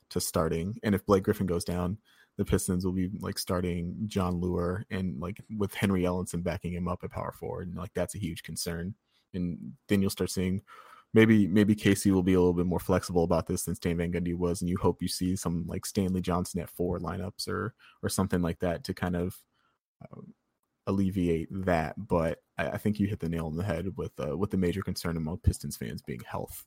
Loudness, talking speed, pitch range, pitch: -30 LUFS, 225 wpm, 85-100 Hz, 90 Hz